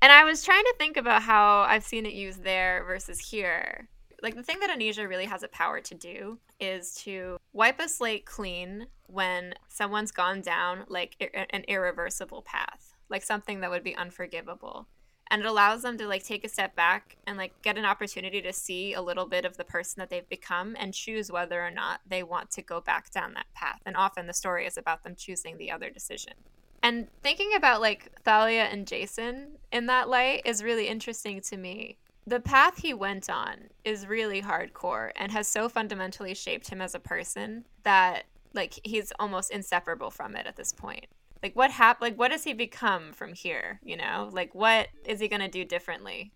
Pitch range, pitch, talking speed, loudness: 185-225 Hz, 205 Hz, 205 wpm, -28 LUFS